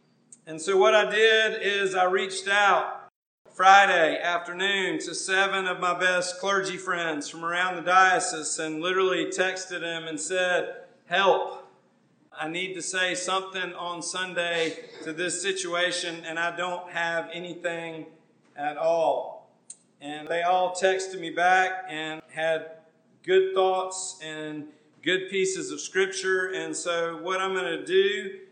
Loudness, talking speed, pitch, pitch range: -25 LUFS, 145 wpm, 180 Hz, 165-190 Hz